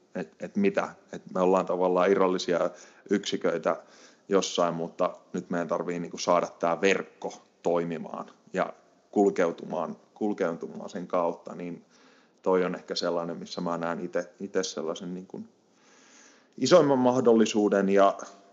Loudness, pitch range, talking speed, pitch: -27 LUFS, 85-100 Hz, 120 wpm, 95 Hz